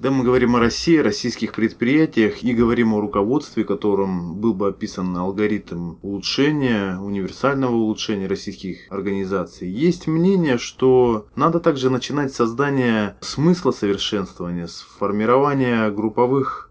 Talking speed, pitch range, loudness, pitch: 120 wpm, 100-130 Hz, -20 LUFS, 110 Hz